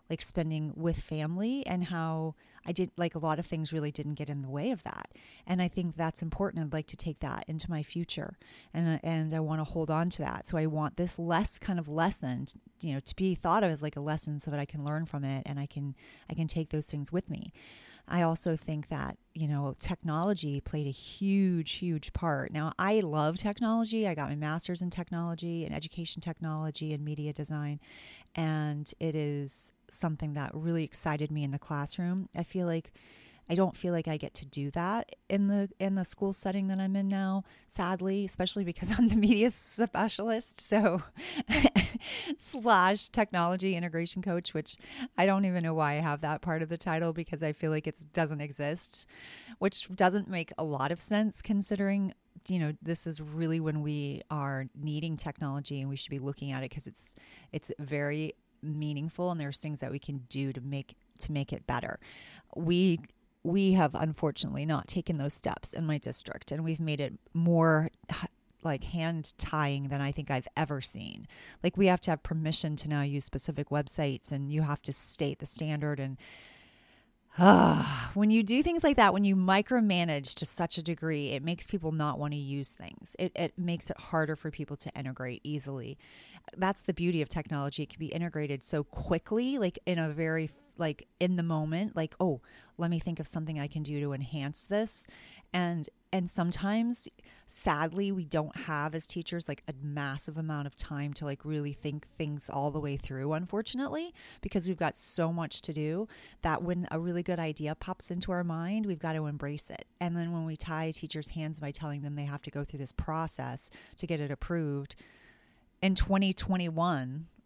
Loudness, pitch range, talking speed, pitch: -33 LUFS, 150-180 Hz, 200 wpm, 160 Hz